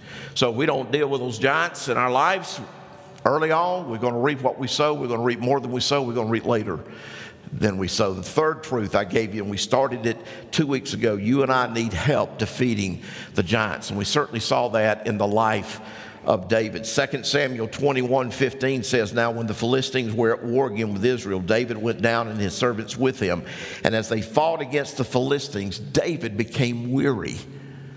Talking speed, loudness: 215 wpm, -23 LUFS